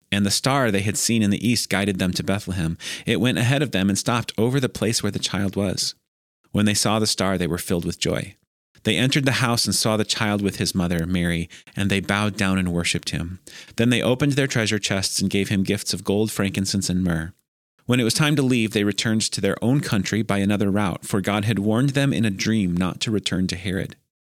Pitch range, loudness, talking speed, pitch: 95-115 Hz, -22 LUFS, 245 wpm, 100 Hz